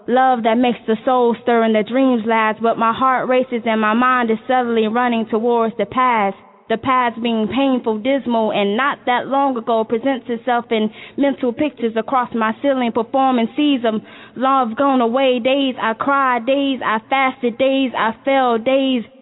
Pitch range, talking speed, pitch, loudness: 225-265 Hz, 175 wpm, 245 Hz, -17 LUFS